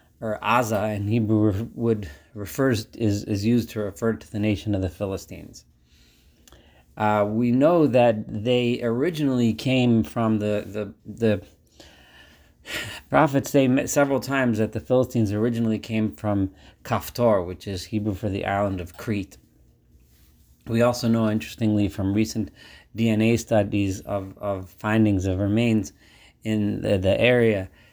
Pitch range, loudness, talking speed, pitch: 100-115 Hz, -23 LUFS, 140 wpm, 105 Hz